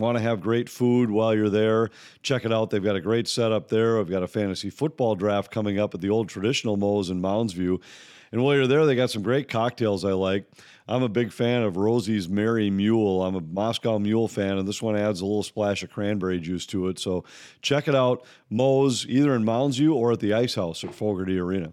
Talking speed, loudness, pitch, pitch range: 230 wpm, -24 LUFS, 110 Hz, 100-120 Hz